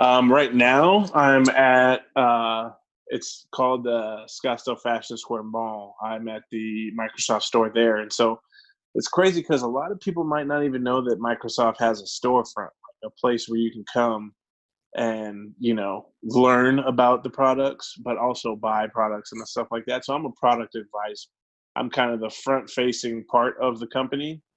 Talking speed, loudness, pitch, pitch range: 180 wpm, -23 LUFS, 120 Hz, 110-130 Hz